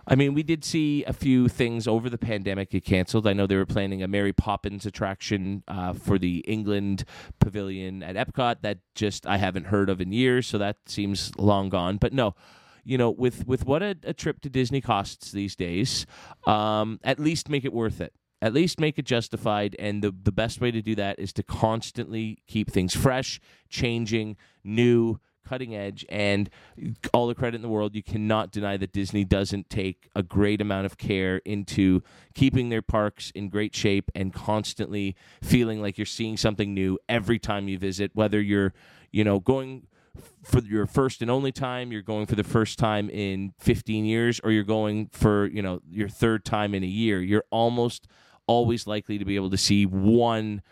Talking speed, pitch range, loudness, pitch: 200 wpm, 100-120 Hz, -26 LUFS, 105 Hz